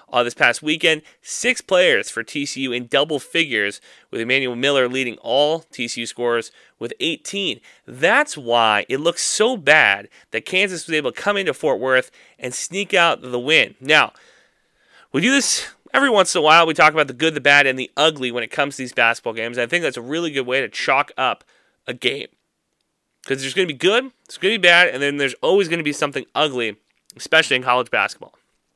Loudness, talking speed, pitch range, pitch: -18 LUFS, 215 wpm, 125-165 Hz, 140 Hz